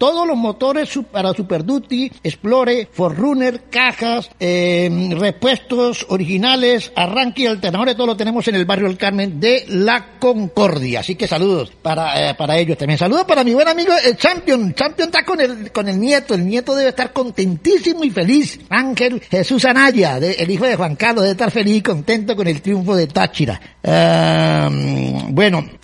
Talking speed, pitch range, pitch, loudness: 175 wpm, 180-255 Hz, 225 Hz, -16 LUFS